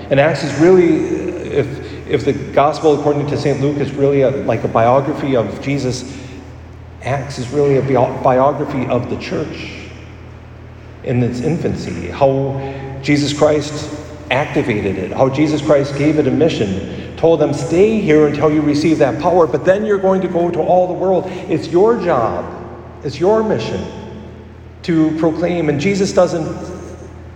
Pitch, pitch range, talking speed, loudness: 145 Hz, 130-160 Hz, 160 wpm, -15 LUFS